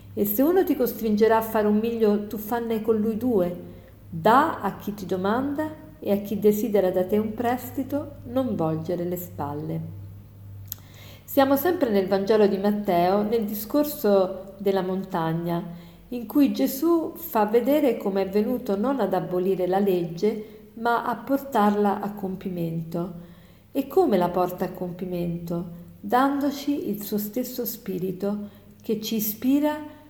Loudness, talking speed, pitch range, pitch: -24 LUFS, 145 wpm, 180-240 Hz, 205 Hz